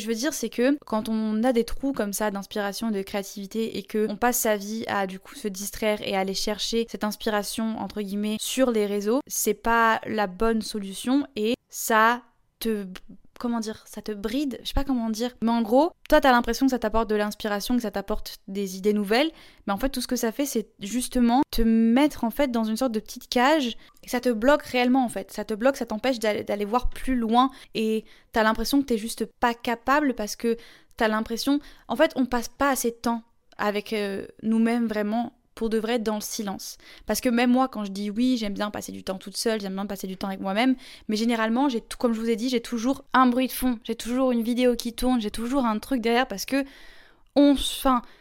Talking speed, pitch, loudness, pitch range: 235 wpm, 230 Hz, -25 LUFS, 215-250 Hz